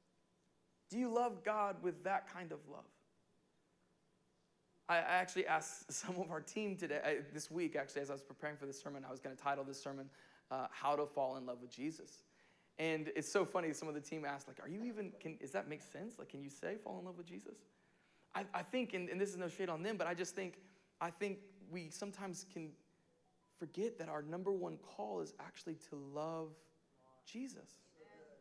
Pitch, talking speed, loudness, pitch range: 170 Hz, 215 wpm, -43 LUFS, 150-195 Hz